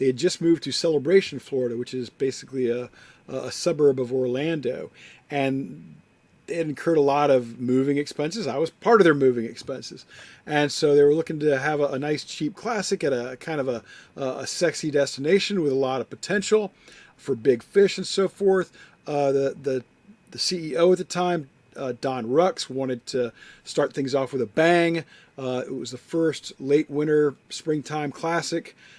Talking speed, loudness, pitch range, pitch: 185 wpm, -24 LUFS, 130-165 Hz, 145 Hz